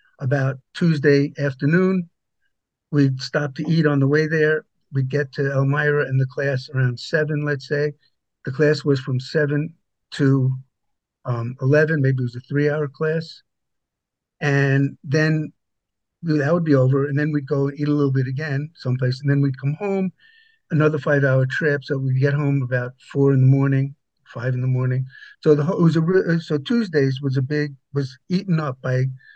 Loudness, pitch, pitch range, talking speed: -21 LUFS, 145 Hz, 135-155 Hz, 175 wpm